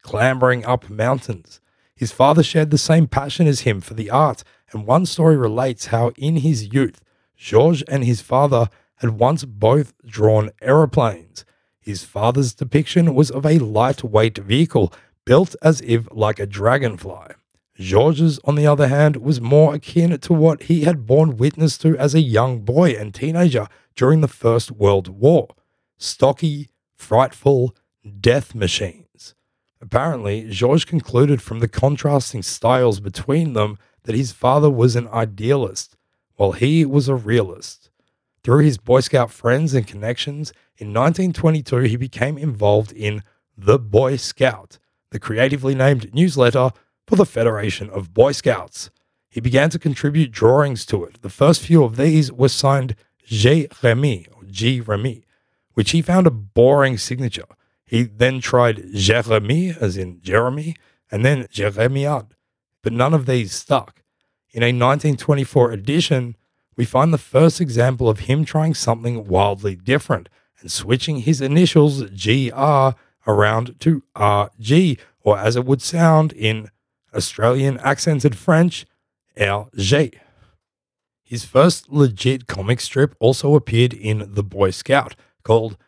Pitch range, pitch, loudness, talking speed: 110-145 Hz, 125 Hz, -17 LUFS, 140 wpm